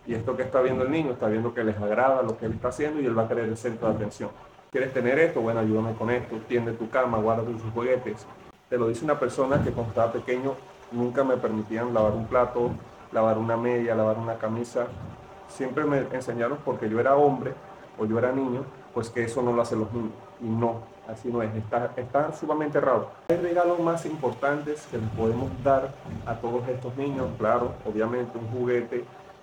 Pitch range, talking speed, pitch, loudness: 115-130 Hz, 210 wpm, 120 Hz, -27 LUFS